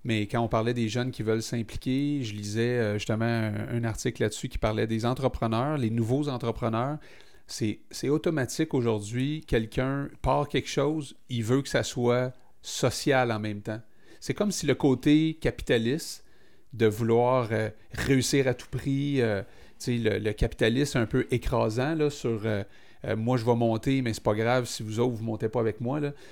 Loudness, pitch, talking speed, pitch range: -28 LUFS, 120 Hz, 185 wpm, 110-135 Hz